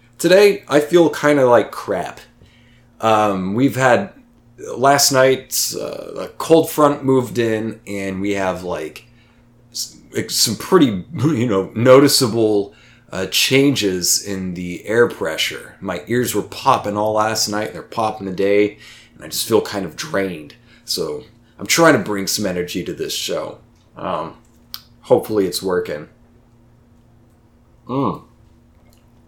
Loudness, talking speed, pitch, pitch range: -17 LUFS, 135 wpm, 120 Hz, 105-130 Hz